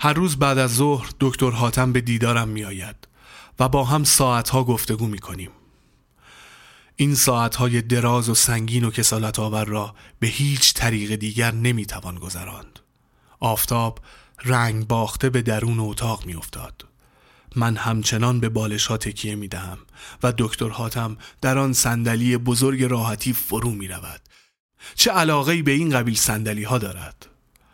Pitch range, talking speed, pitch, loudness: 110-125 Hz, 155 wpm, 115 Hz, -21 LUFS